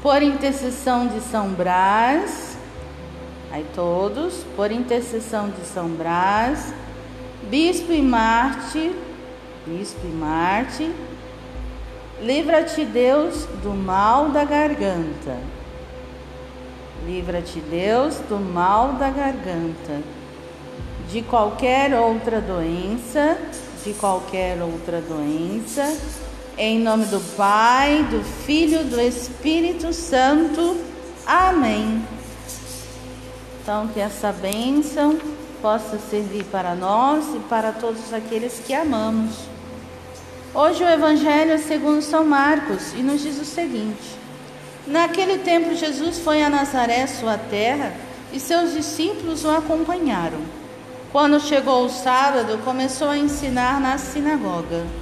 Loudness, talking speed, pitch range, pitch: -21 LUFS, 105 wpm, 195-295 Hz, 245 Hz